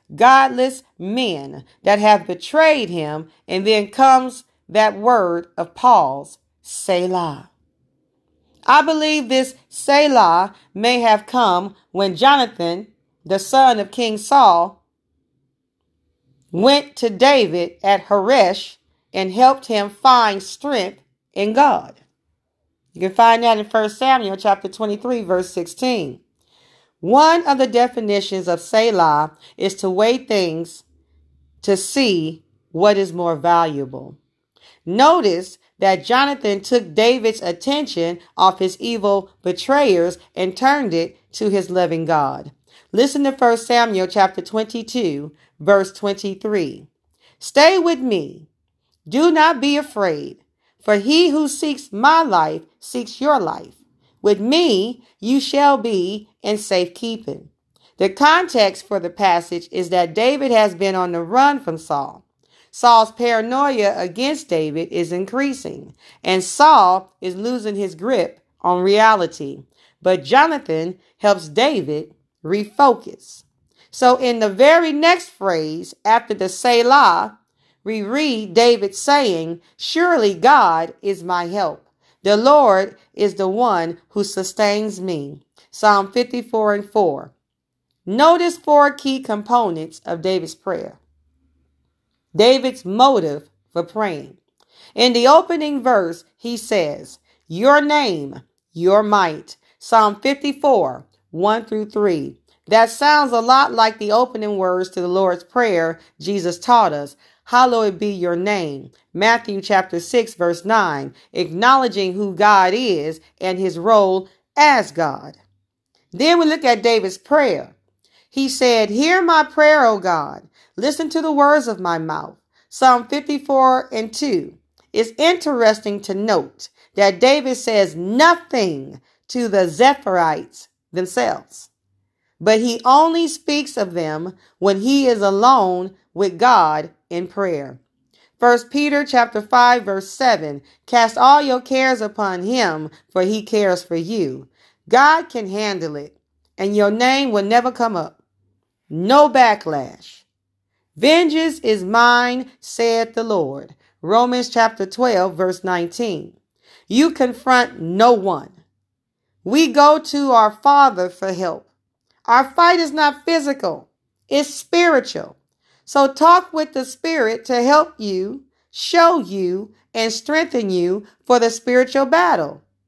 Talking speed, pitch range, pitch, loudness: 125 wpm, 180-260 Hz, 215 Hz, -16 LUFS